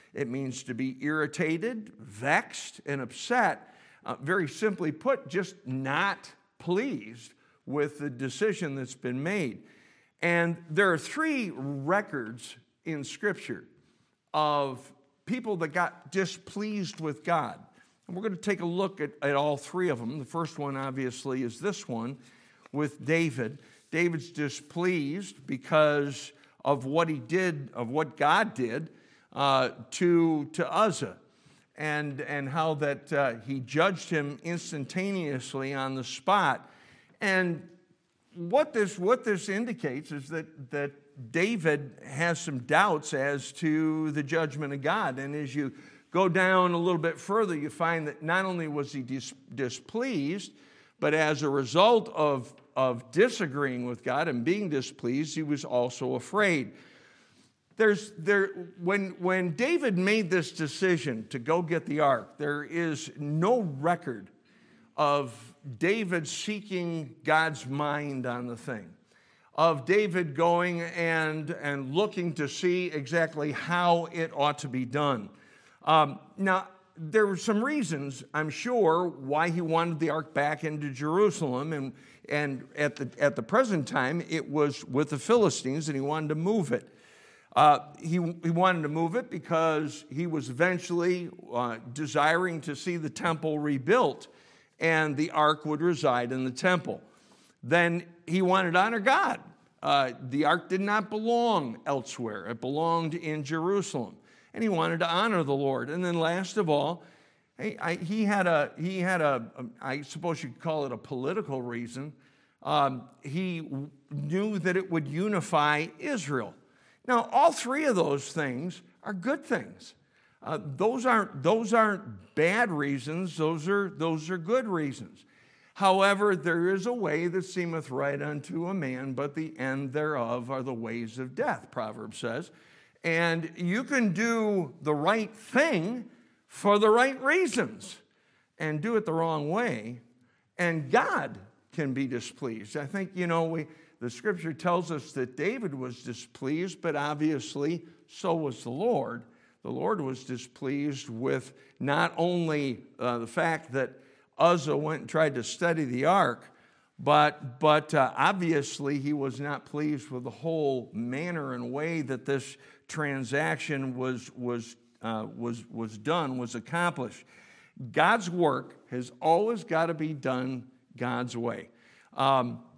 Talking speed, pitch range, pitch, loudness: 150 wpm, 140-180 Hz, 155 Hz, -29 LUFS